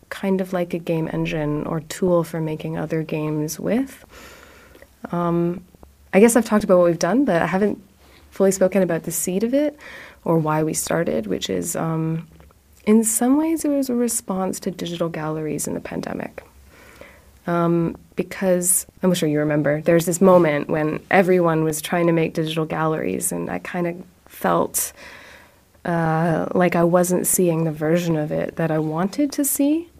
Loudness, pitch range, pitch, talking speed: -21 LUFS, 160-195 Hz, 175 Hz, 175 wpm